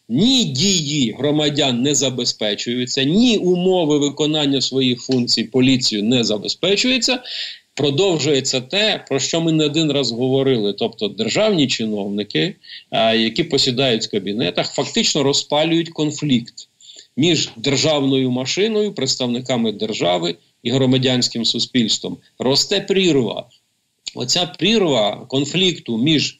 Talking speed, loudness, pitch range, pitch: 105 wpm, -17 LUFS, 125-170 Hz, 140 Hz